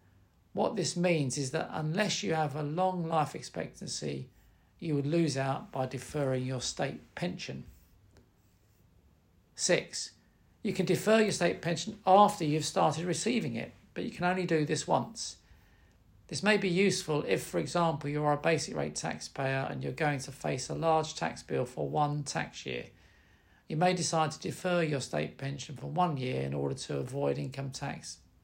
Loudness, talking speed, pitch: -32 LUFS, 175 wpm, 150 Hz